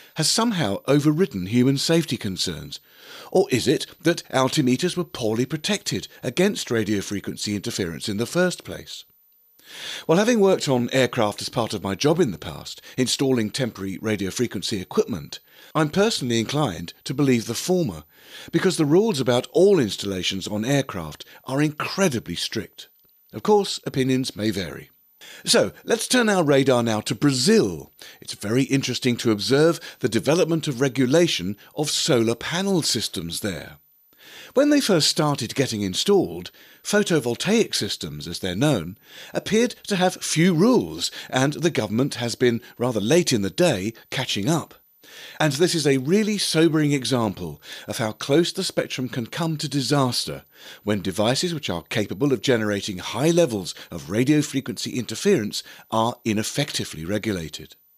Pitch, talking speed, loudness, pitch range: 130 Hz, 150 wpm, -22 LUFS, 110-165 Hz